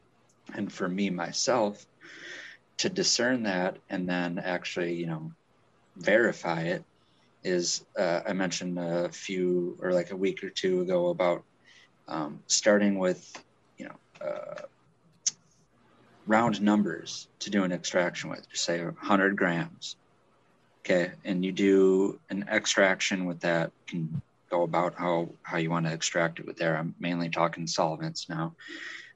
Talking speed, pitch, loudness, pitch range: 145 wpm, 90 Hz, -29 LUFS, 85-95 Hz